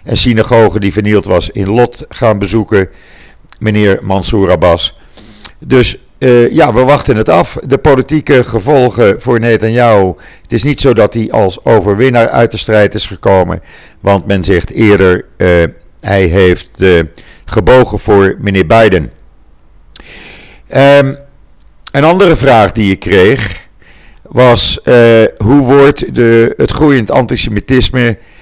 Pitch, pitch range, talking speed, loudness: 110 Hz, 95-125 Hz, 135 wpm, -8 LUFS